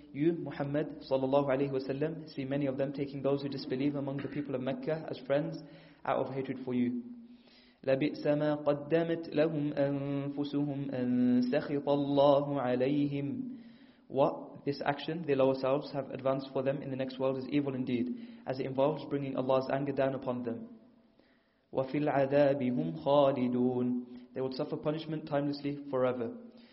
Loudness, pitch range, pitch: -33 LUFS, 135-150 Hz, 140 Hz